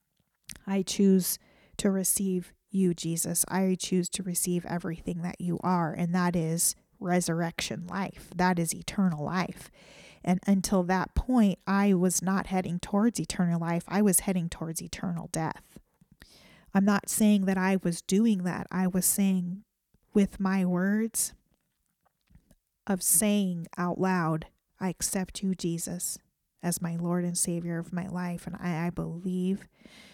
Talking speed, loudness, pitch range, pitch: 145 wpm, -28 LUFS, 175-195 Hz, 185 Hz